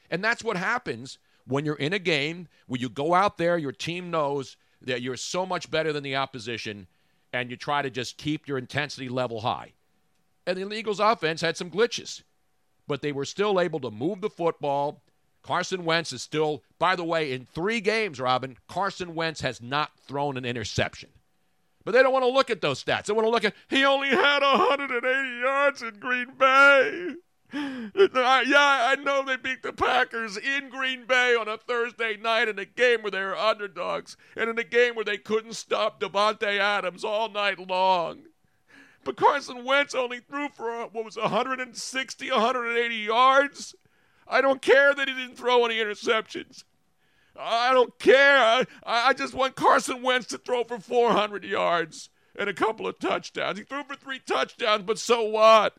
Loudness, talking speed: -25 LUFS, 185 wpm